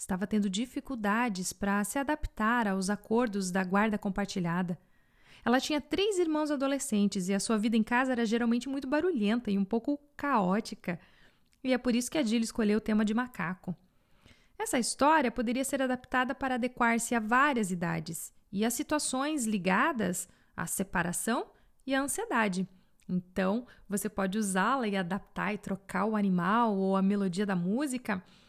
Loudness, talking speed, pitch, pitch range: -30 LUFS, 160 wpm, 220 Hz, 195-255 Hz